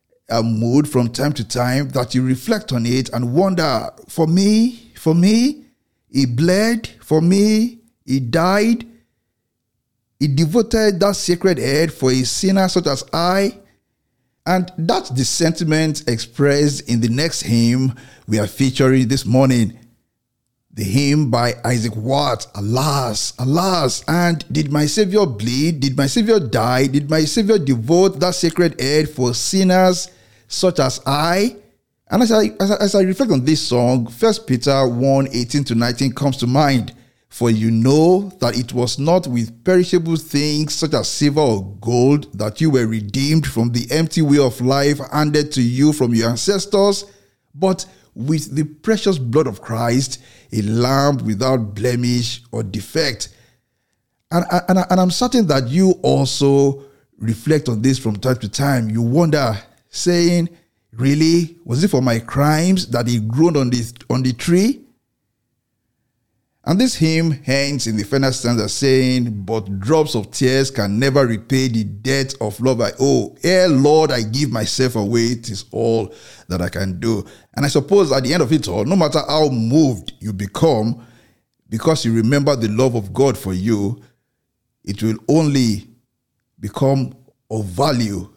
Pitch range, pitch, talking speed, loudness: 120-160 Hz, 135 Hz, 160 wpm, -17 LUFS